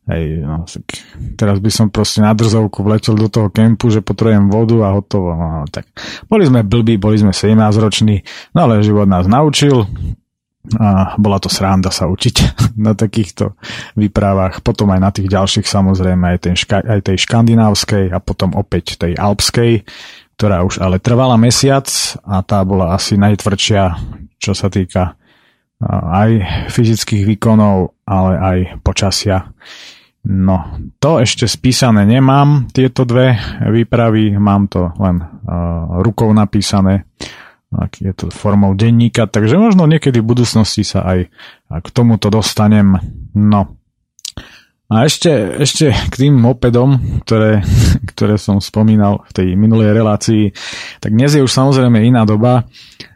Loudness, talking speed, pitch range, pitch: -12 LUFS, 140 wpm, 95-115 Hz, 105 Hz